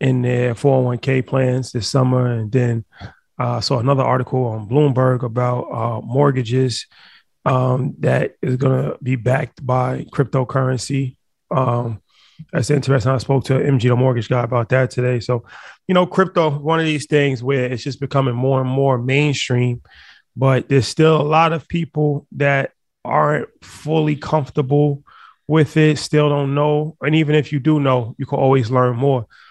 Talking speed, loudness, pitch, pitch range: 165 wpm, -18 LUFS, 135 Hz, 125-145 Hz